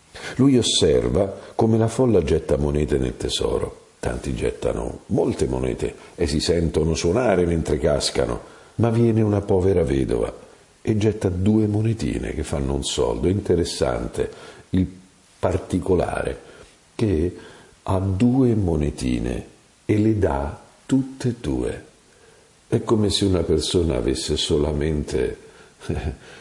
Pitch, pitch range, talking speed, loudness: 95 Hz, 75-115 Hz, 120 wpm, -22 LUFS